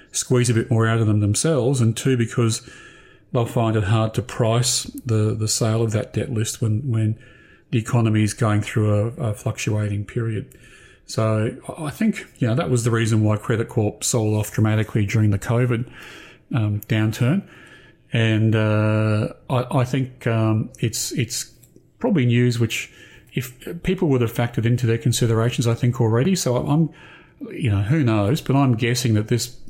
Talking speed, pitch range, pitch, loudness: 180 wpm, 110-125 Hz, 115 Hz, -21 LUFS